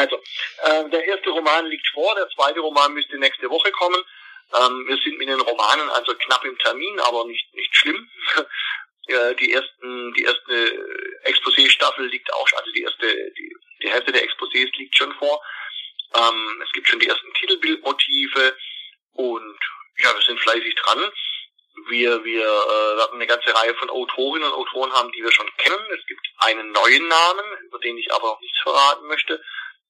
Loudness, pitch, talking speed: -19 LUFS, 305 Hz, 170 wpm